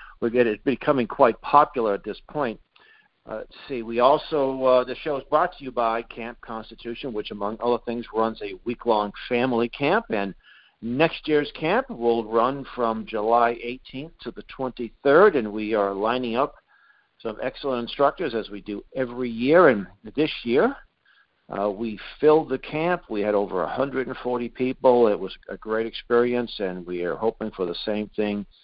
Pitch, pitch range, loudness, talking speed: 120 Hz, 110-130 Hz, -24 LUFS, 175 wpm